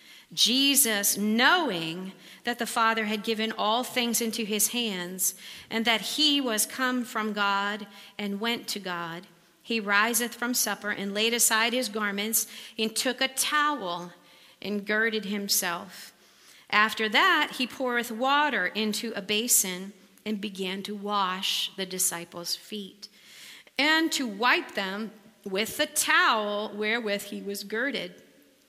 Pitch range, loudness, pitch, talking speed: 200-235 Hz, -26 LUFS, 215 Hz, 135 wpm